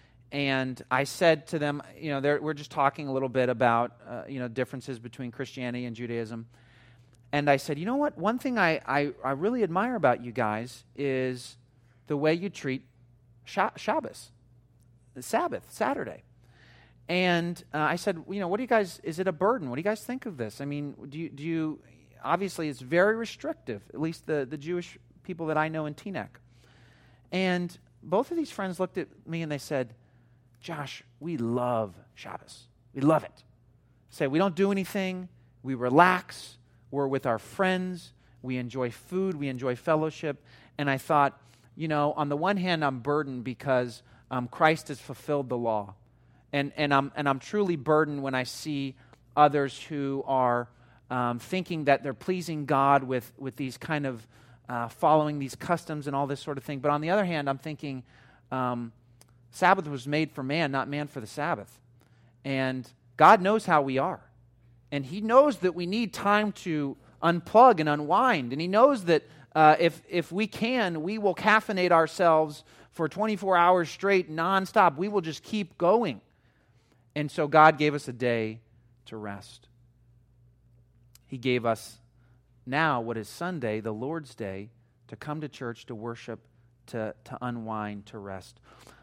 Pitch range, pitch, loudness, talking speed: 120-165 Hz, 140 Hz, -28 LUFS, 180 wpm